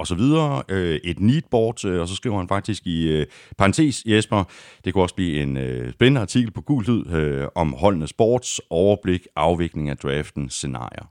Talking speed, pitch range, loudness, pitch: 185 wpm, 80-115 Hz, -22 LUFS, 95 Hz